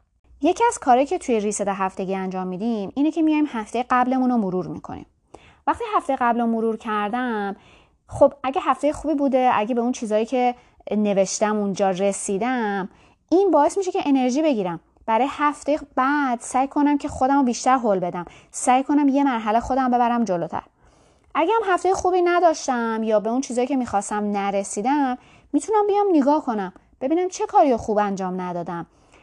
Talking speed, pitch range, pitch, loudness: 170 wpm, 210-290 Hz, 250 Hz, -21 LUFS